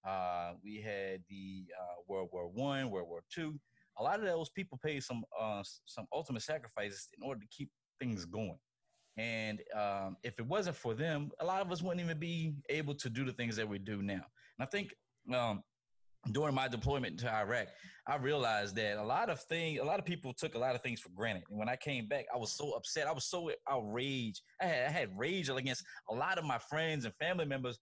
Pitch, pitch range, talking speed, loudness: 120 Hz, 105-150 Hz, 230 wpm, -39 LUFS